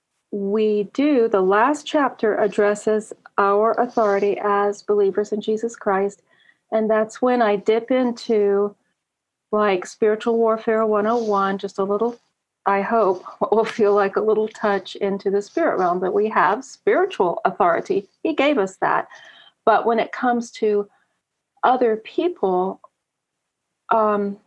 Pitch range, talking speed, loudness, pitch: 200-230 Hz, 135 wpm, -20 LUFS, 215 Hz